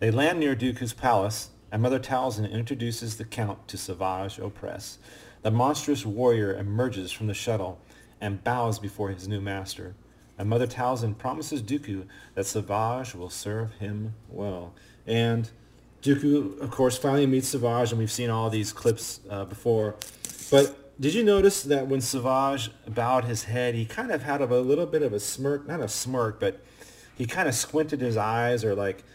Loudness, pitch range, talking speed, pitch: -27 LUFS, 105-130 Hz, 175 wpm, 115 Hz